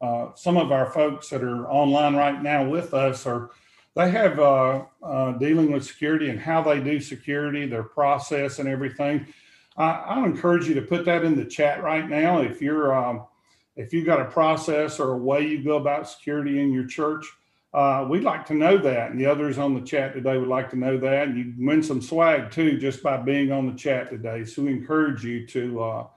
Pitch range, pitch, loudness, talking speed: 130-150 Hz, 140 Hz, -23 LUFS, 220 wpm